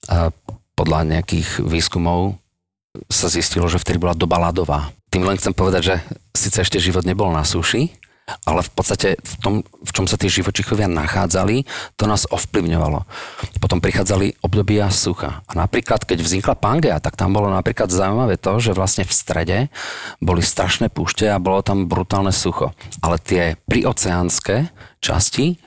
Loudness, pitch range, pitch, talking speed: -17 LUFS, 85-100 Hz, 95 Hz, 155 wpm